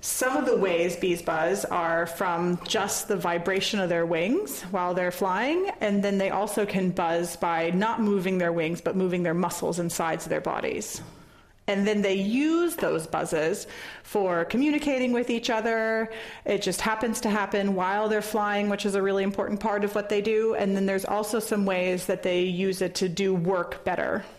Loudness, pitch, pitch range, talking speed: -26 LUFS, 195 Hz, 180-215 Hz, 195 wpm